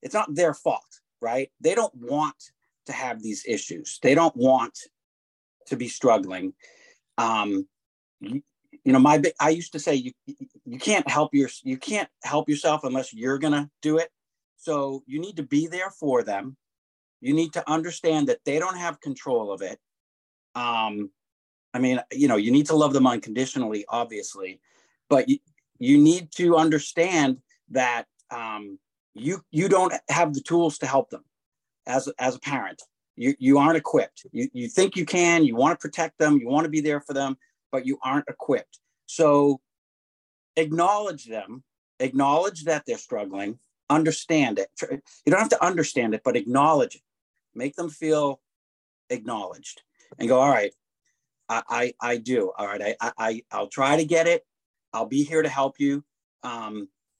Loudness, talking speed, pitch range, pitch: -24 LUFS, 175 wpm, 130-170 Hz, 150 Hz